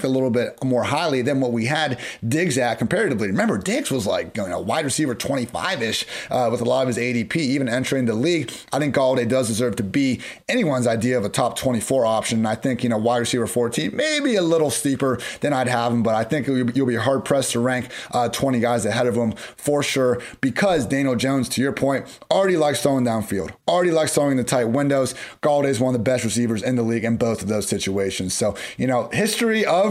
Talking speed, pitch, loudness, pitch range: 235 wpm, 125 Hz, -21 LUFS, 120-135 Hz